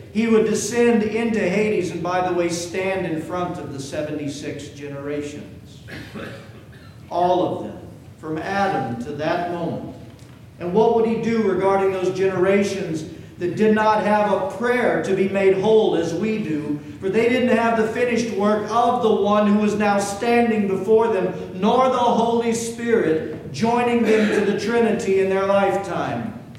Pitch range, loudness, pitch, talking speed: 170-220 Hz, -20 LUFS, 195 Hz, 165 wpm